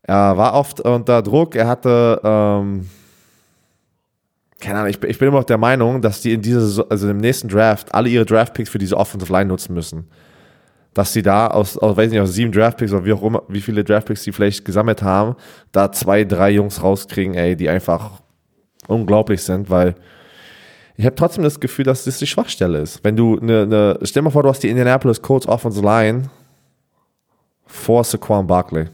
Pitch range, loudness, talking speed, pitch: 100-120 Hz, -16 LUFS, 195 wpm, 105 Hz